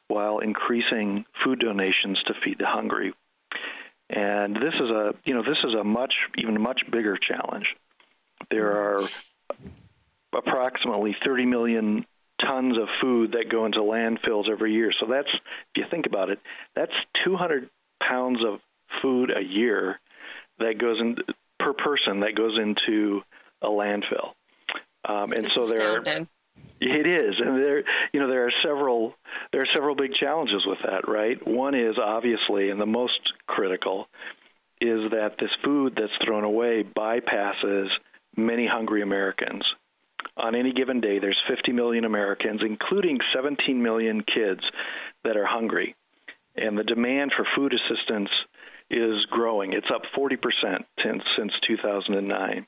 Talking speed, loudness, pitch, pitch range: 145 wpm, -25 LUFS, 110 Hz, 105-120 Hz